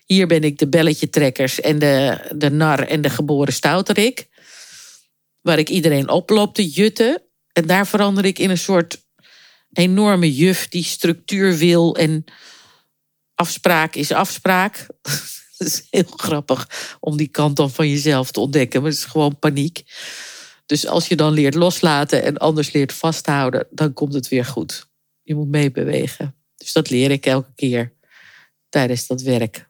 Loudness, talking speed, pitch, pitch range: -17 LUFS, 160 wpm, 155 Hz, 145-175 Hz